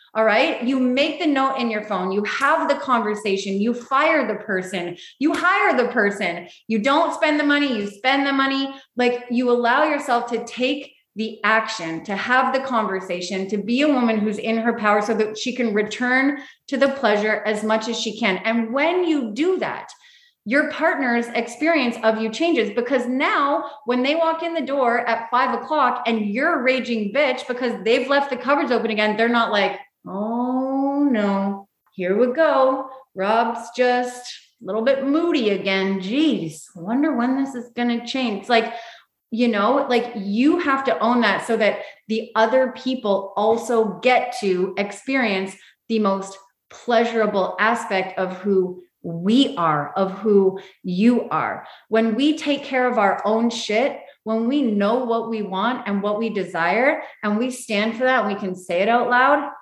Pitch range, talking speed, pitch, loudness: 210-265 Hz, 185 wpm, 235 Hz, -20 LUFS